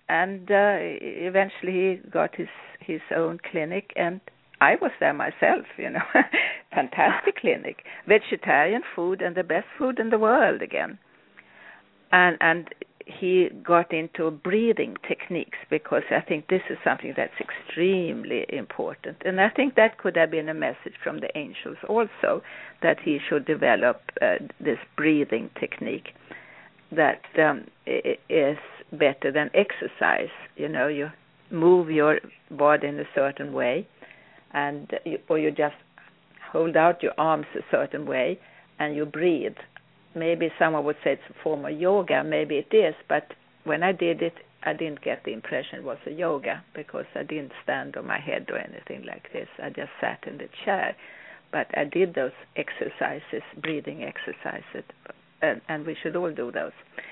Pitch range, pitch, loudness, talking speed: 155-195 Hz, 170 Hz, -25 LUFS, 160 wpm